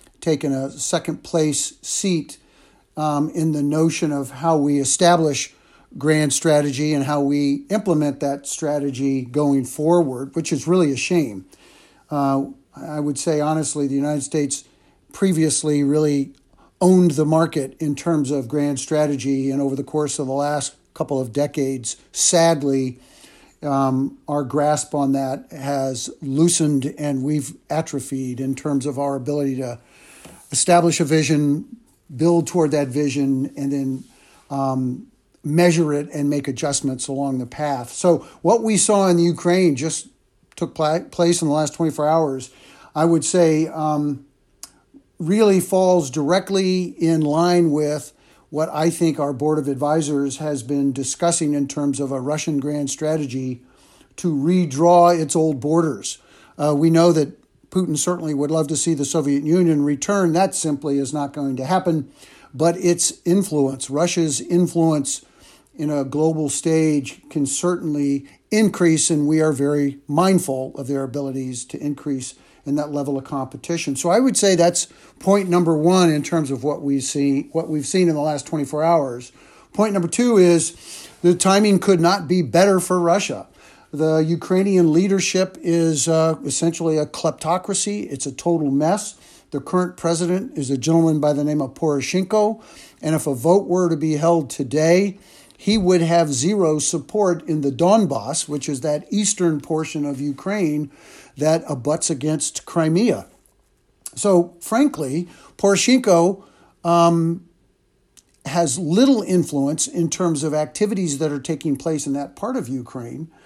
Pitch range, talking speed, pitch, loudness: 140-170 Hz, 155 wpm, 155 Hz, -20 LUFS